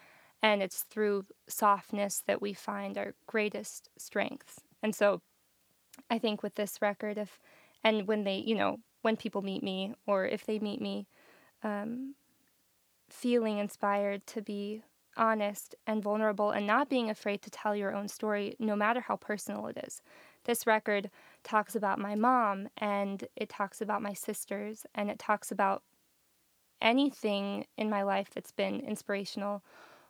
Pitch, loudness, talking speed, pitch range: 210 Hz, -33 LUFS, 155 wpm, 200-220 Hz